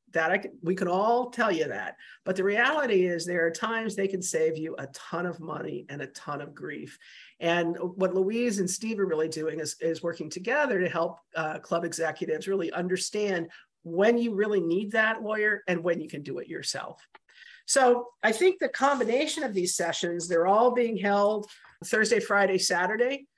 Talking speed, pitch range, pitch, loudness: 195 wpm, 170-225 Hz, 190 Hz, -27 LUFS